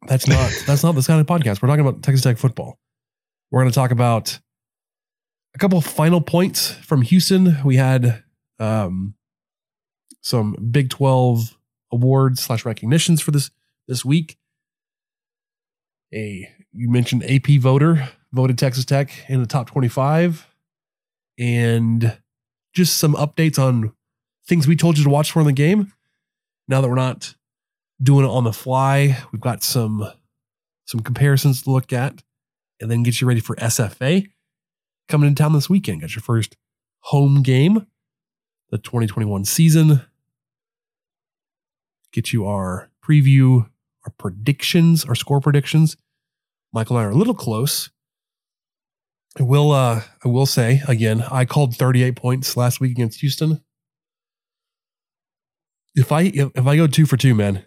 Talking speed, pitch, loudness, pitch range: 150 wpm, 135 Hz, -18 LUFS, 125-155 Hz